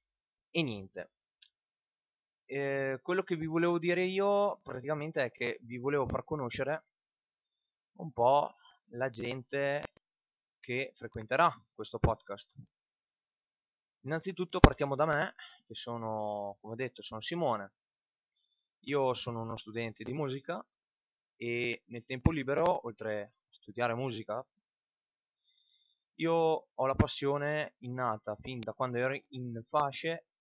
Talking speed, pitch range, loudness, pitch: 120 wpm, 115-155 Hz, -34 LUFS, 130 Hz